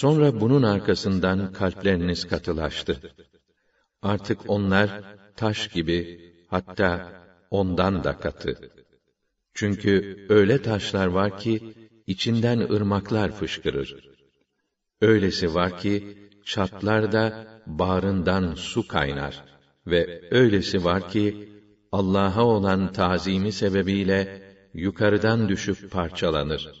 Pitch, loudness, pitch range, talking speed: 100 Hz, -24 LUFS, 90-105 Hz, 85 wpm